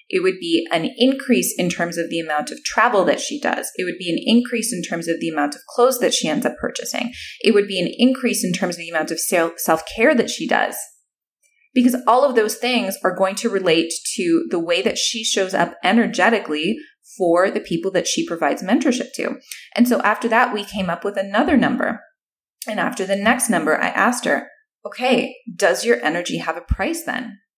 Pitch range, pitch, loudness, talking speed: 180-250 Hz, 220 Hz, -19 LUFS, 215 wpm